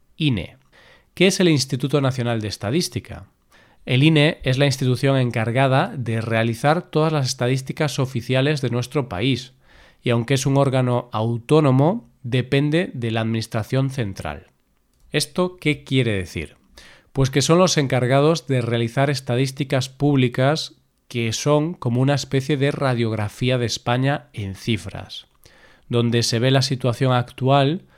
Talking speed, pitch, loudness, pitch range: 135 wpm, 130 Hz, -20 LUFS, 120-145 Hz